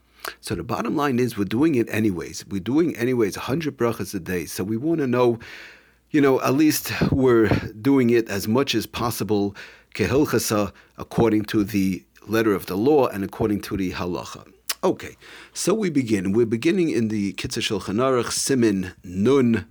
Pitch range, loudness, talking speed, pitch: 100-125 Hz, -22 LUFS, 170 wpm, 110 Hz